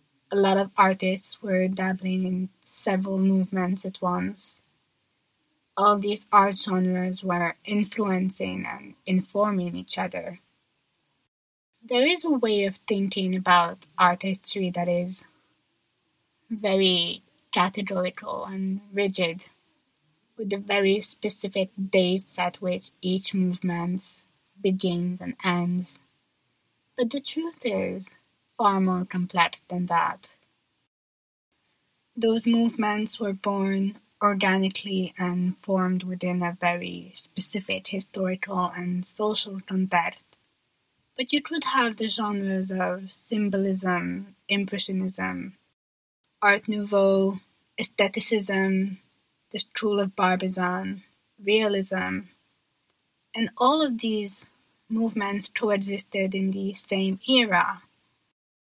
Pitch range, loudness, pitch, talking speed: 180-205 Hz, -26 LUFS, 190 Hz, 100 wpm